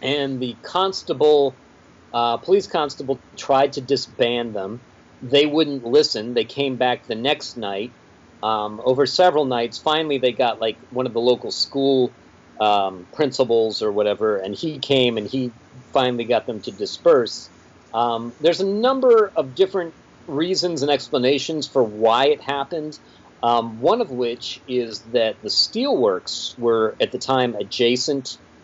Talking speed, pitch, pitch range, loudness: 150 wpm, 130 Hz, 120-150 Hz, -21 LUFS